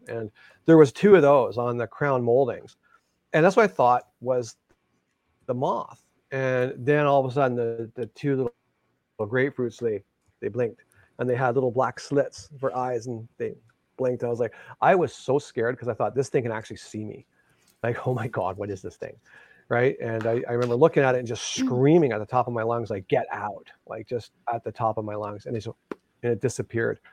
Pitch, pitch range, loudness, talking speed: 125 Hz, 115-135 Hz, -25 LUFS, 230 wpm